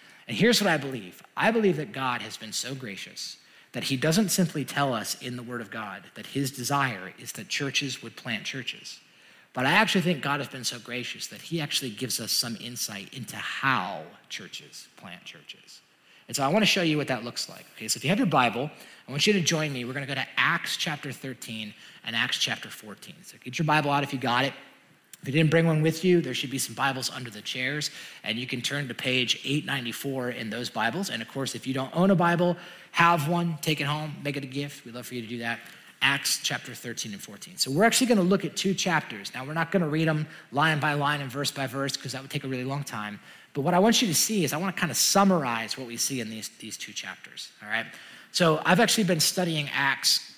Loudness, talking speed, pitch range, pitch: -26 LUFS, 255 wpm, 125-165 Hz, 140 Hz